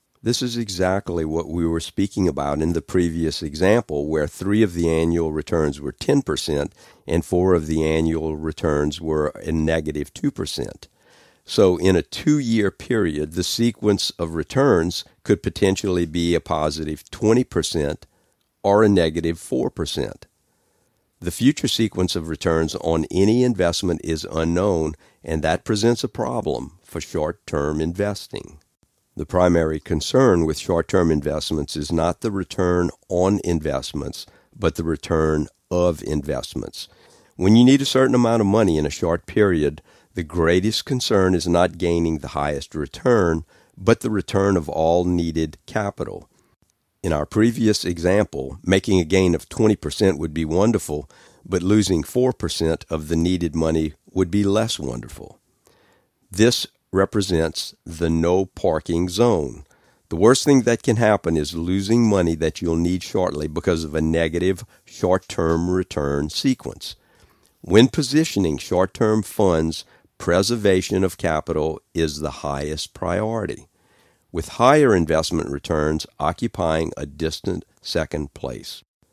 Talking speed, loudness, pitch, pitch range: 140 wpm, -21 LUFS, 85 Hz, 80-100 Hz